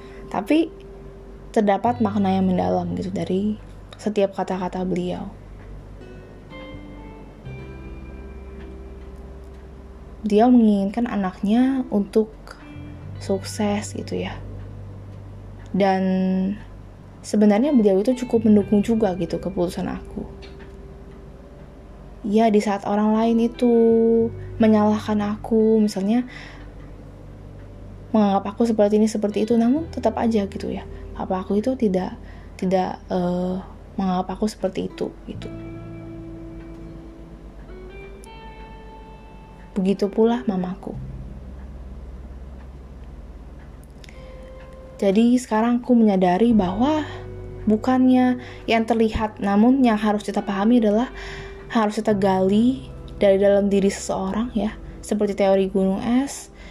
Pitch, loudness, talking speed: 190 Hz, -21 LUFS, 90 wpm